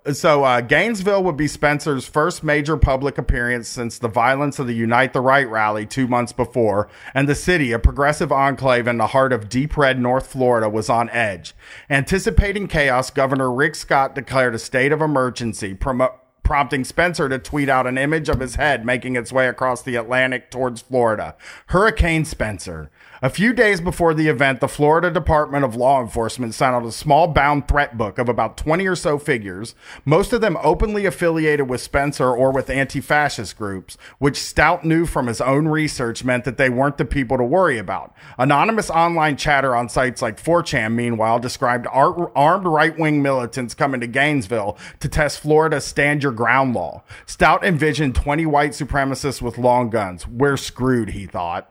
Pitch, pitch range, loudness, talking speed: 135 Hz, 120-150 Hz, -18 LUFS, 180 wpm